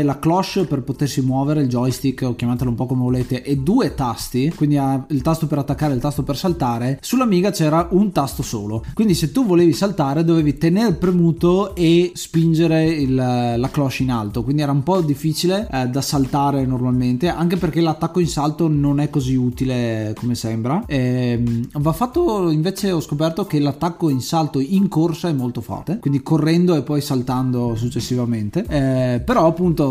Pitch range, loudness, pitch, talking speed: 130-165 Hz, -19 LUFS, 145 Hz, 185 wpm